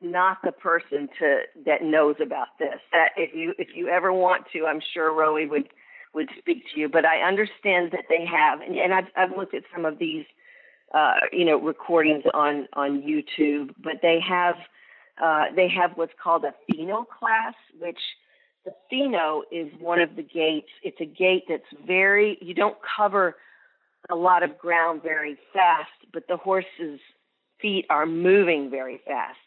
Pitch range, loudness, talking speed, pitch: 155-185 Hz, -23 LUFS, 175 wpm, 170 Hz